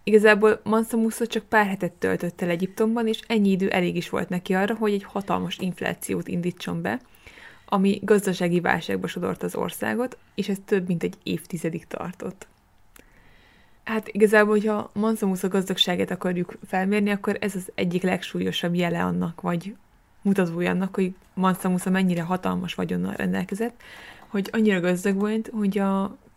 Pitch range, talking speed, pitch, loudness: 180-215 Hz, 150 wpm, 195 Hz, -24 LUFS